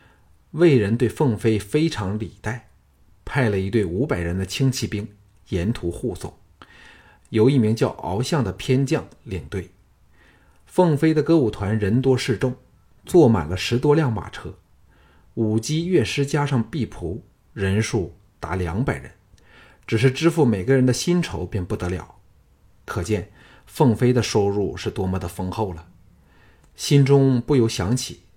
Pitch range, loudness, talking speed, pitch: 95-130 Hz, -21 LUFS, 215 characters per minute, 110 Hz